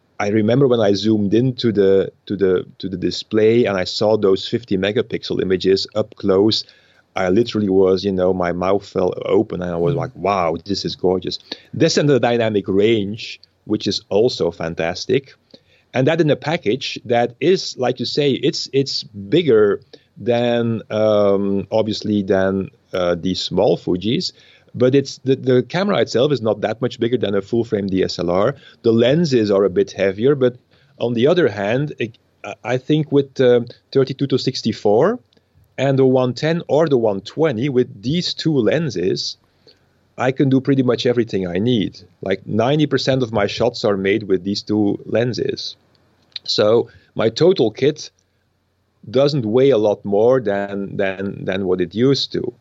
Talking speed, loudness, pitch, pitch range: 170 wpm, -18 LUFS, 110 Hz, 100-130 Hz